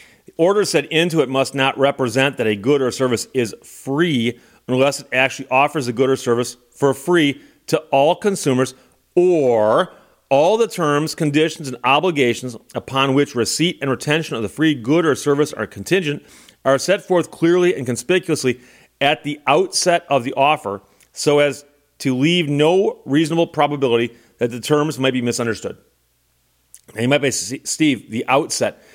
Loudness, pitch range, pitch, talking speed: -18 LUFS, 125-155 Hz, 140 Hz, 165 wpm